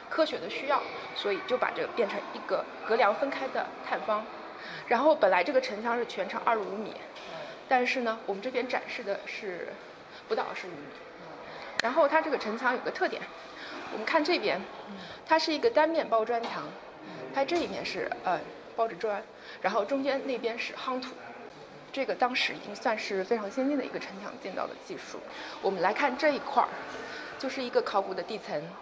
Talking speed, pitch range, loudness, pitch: 285 characters per minute, 230-300 Hz, -30 LUFS, 255 Hz